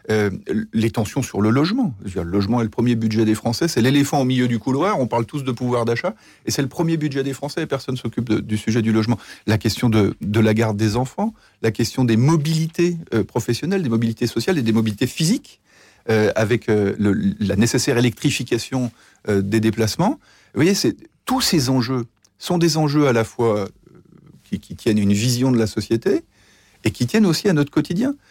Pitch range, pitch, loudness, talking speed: 110-145 Hz, 120 Hz, -20 LUFS, 215 wpm